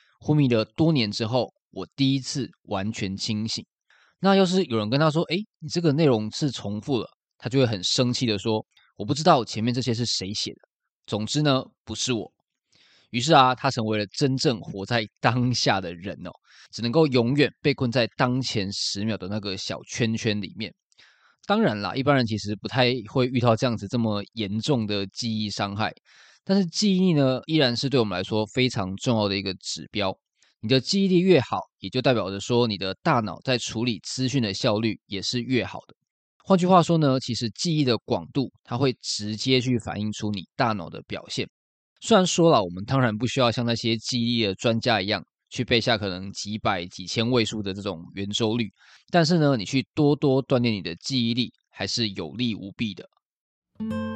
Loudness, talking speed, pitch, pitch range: -24 LUFS, 285 characters per minute, 120 Hz, 105-135 Hz